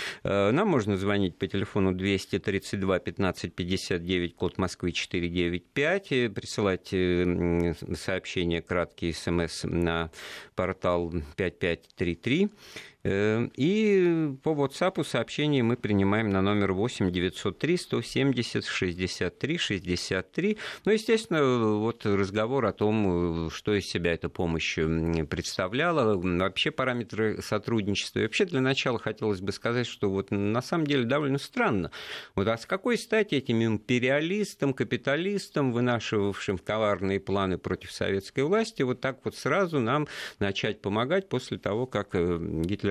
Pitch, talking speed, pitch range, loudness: 105 Hz, 110 wpm, 95-135 Hz, -28 LUFS